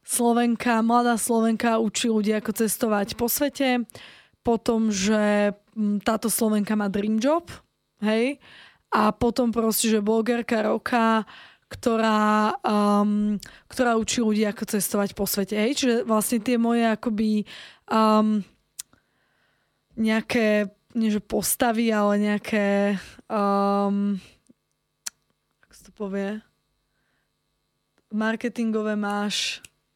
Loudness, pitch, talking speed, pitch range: -23 LUFS, 220 Hz, 100 wpm, 210-235 Hz